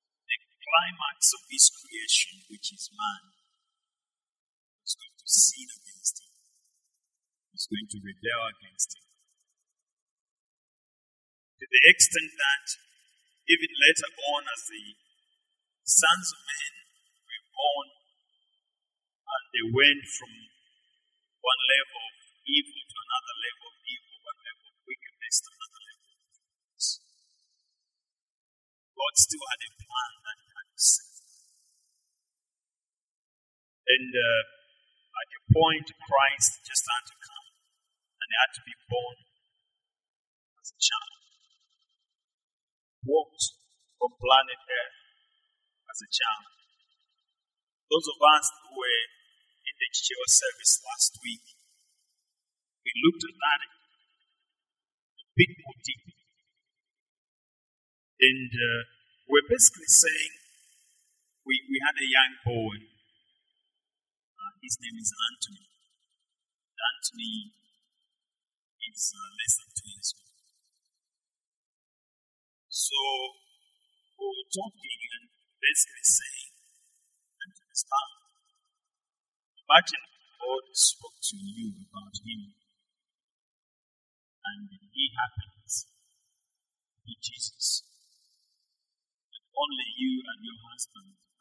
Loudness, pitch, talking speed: -25 LUFS, 330 Hz, 105 wpm